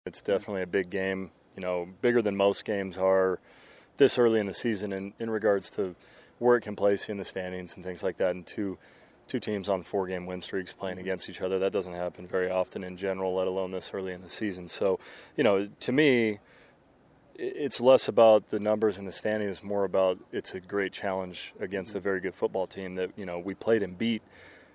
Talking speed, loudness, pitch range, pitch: 220 wpm, -29 LUFS, 90-105 Hz, 95 Hz